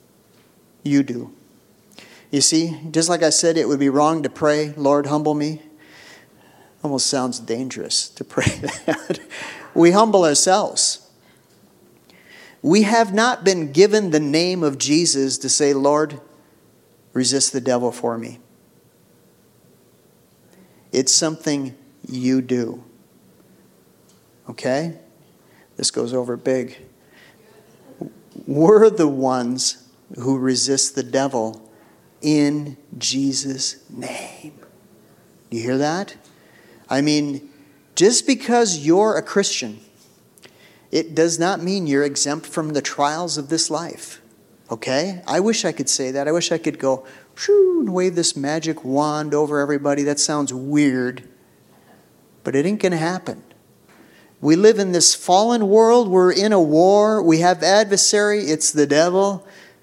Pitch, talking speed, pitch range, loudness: 150 Hz, 130 wpm, 135-175 Hz, -18 LUFS